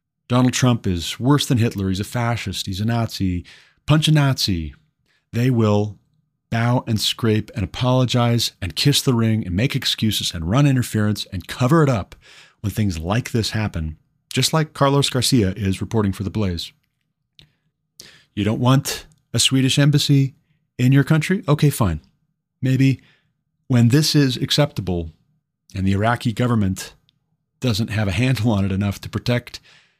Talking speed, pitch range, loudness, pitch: 160 wpm, 105-140 Hz, -19 LUFS, 125 Hz